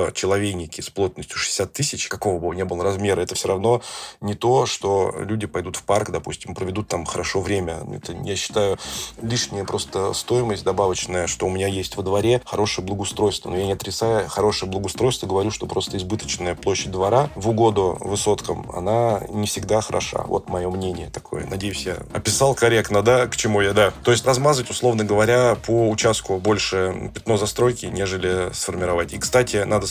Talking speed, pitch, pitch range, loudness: 175 wpm, 100 Hz, 95-115 Hz, -21 LUFS